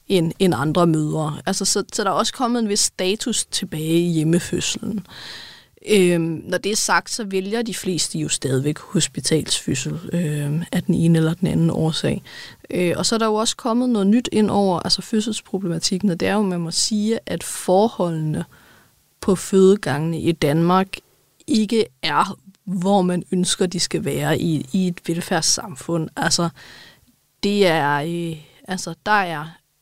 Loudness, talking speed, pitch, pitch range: -20 LUFS, 165 wpm, 180 Hz, 165-200 Hz